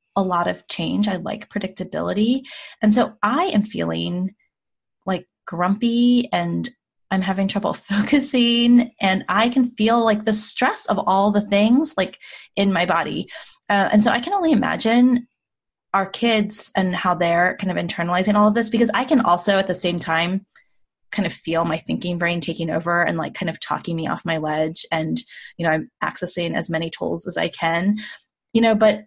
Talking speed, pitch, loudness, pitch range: 190 wpm, 195 Hz, -20 LUFS, 175-225 Hz